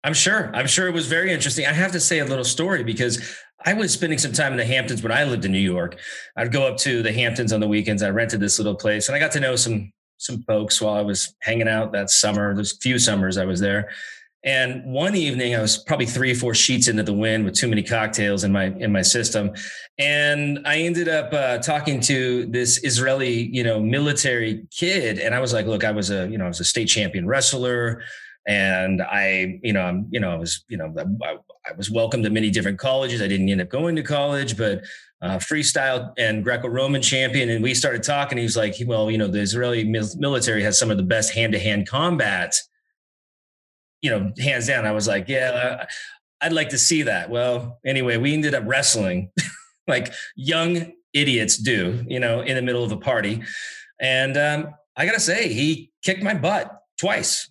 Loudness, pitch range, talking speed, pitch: -21 LUFS, 105-140 Hz, 220 wpm, 120 Hz